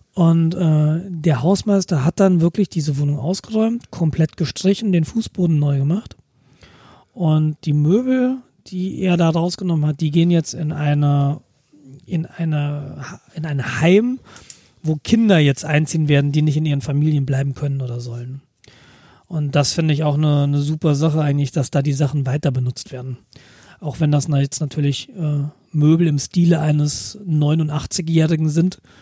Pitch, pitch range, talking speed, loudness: 155 Hz, 145-170 Hz, 160 wpm, -18 LUFS